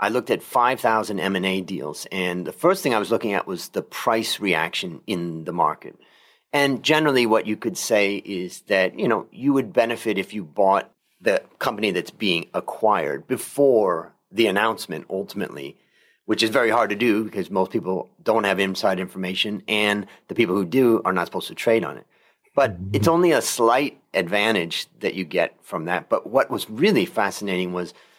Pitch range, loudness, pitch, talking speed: 95-115 Hz, -22 LUFS, 100 Hz, 185 wpm